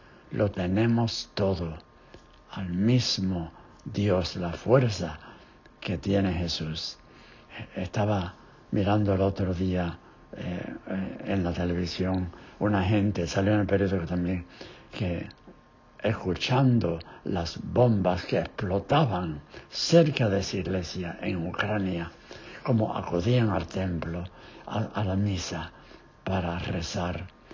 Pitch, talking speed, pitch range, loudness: 95 Hz, 105 wpm, 90-105 Hz, -28 LUFS